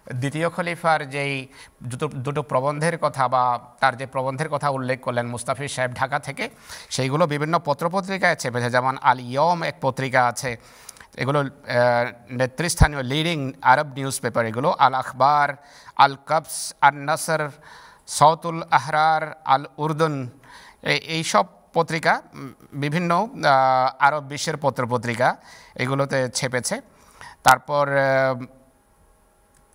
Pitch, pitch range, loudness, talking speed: 140 Hz, 130-155 Hz, -22 LUFS, 110 wpm